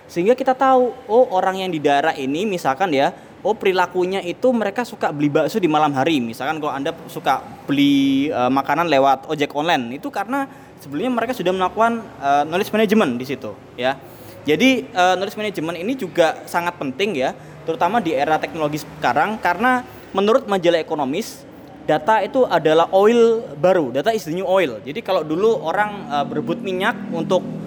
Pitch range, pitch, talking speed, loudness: 155-225 Hz, 180 Hz, 170 wpm, -19 LUFS